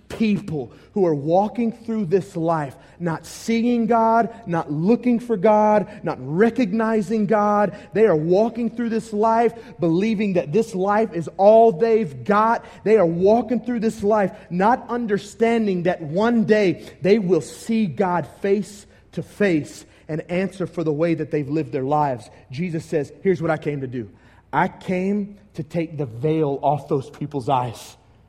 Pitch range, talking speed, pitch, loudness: 160-220 Hz, 165 wpm, 195 Hz, -21 LUFS